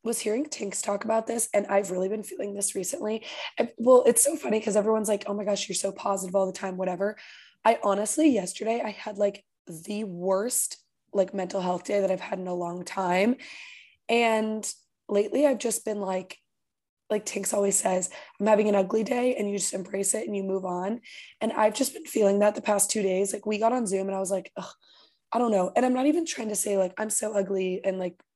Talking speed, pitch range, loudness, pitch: 230 wpm, 195-220 Hz, -26 LUFS, 205 Hz